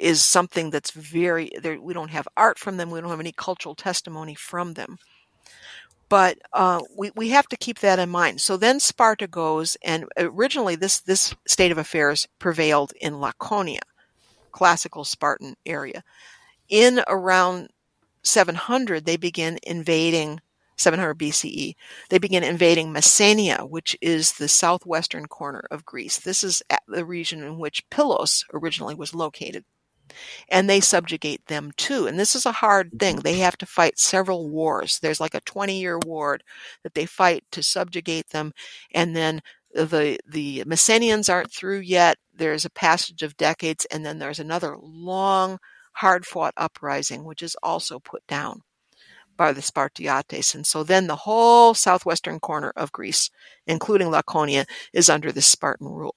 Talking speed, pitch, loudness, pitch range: 160 wpm, 170 Hz, -21 LUFS, 160-190 Hz